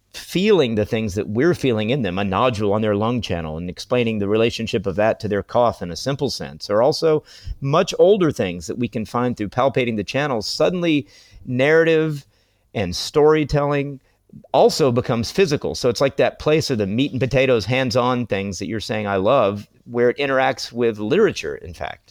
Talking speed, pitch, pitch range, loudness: 195 wpm, 120 Hz, 105-135 Hz, -20 LUFS